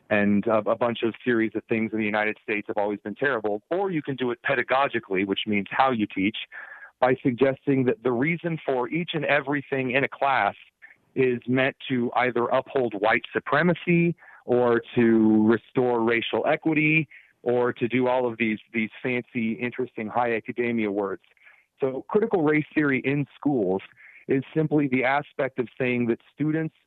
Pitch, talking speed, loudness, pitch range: 125 Hz, 170 wpm, -25 LUFS, 110-140 Hz